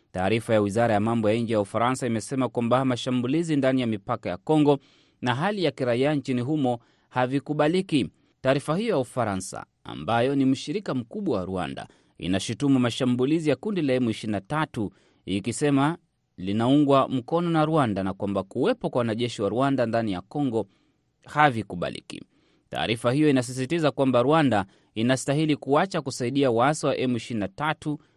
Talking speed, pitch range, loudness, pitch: 145 wpm, 115-145 Hz, -25 LUFS, 130 Hz